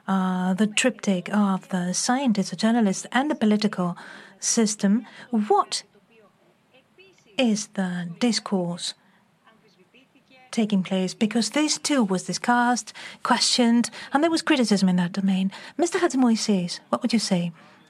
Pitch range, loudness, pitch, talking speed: 190-245 Hz, -23 LUFS, 215 Hz, 125 wpm